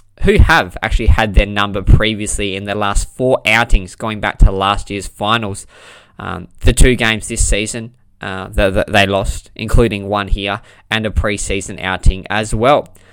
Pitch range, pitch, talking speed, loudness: 100-110 Hz, 100 Hz, 175 wpm, -15 LUFS